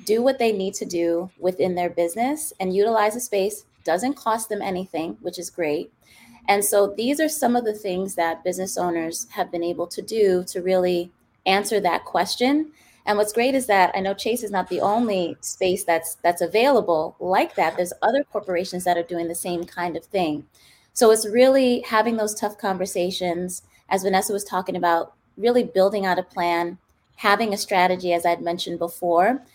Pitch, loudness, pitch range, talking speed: 190 Hz, -22 LUFS, 175-215 Hz, 190 wpm